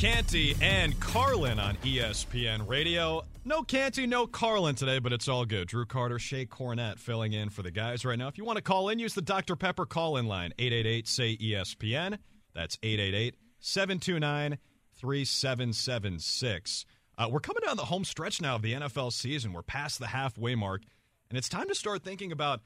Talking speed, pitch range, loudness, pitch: 170 wpm, 110-160 Hz, -31 LUFS, 125 Hz